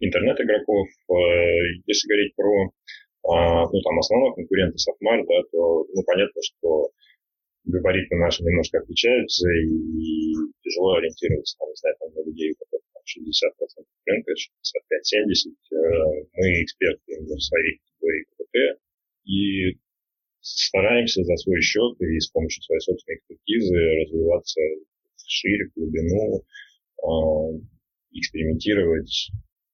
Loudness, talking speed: -22 LUFS, 105 wpm